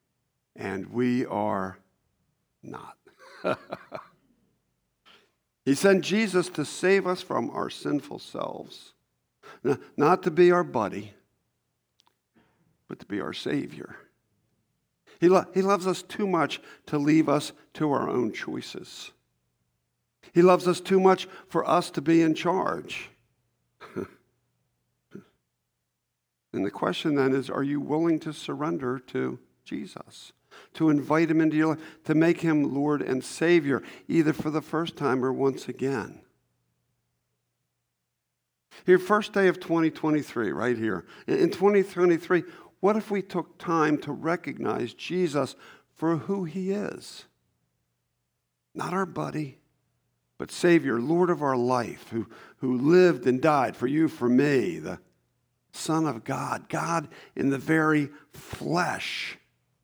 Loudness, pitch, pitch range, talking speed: -26 LUFS, 155 Hz, 120-175 Hz, 130 wpm